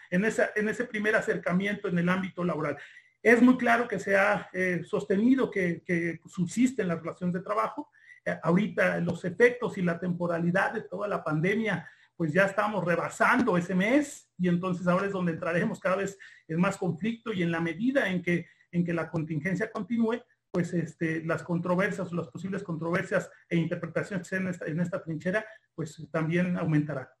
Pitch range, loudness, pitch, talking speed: 170-210 Hz, -28 LUFS, 185 Hz, 180 wpm